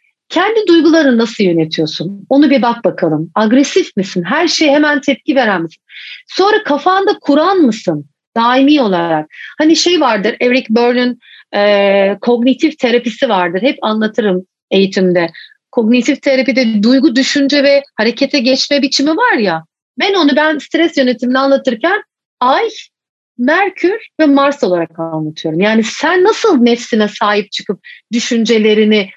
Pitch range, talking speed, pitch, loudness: 210-295 Hz, 130 wpm, 255 Hz, -12 LUFS